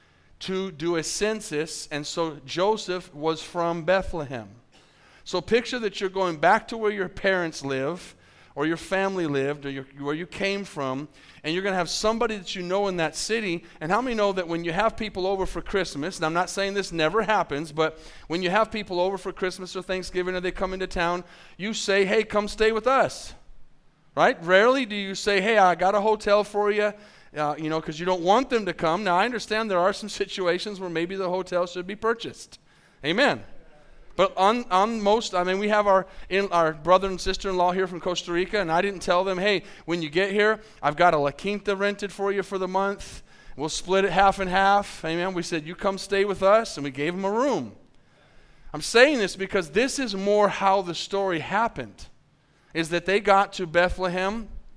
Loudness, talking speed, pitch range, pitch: -25 LUFS, 215 wpm, 170-200 Hz, 190 Hz